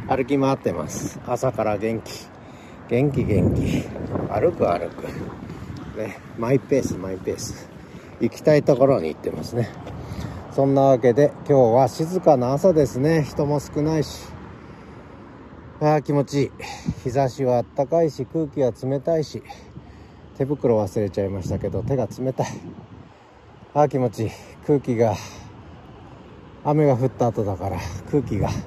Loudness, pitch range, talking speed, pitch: -22 LUFS, 105-140 Hz, 270 characters per minute, 125 Hz